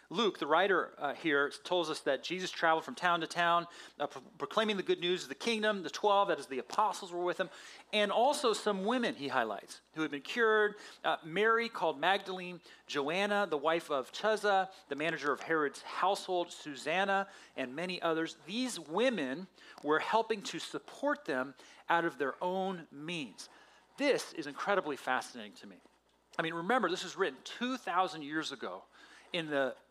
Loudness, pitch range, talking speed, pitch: -34 LUFS, 160-210 Hz, 180 wpm, 180 Hz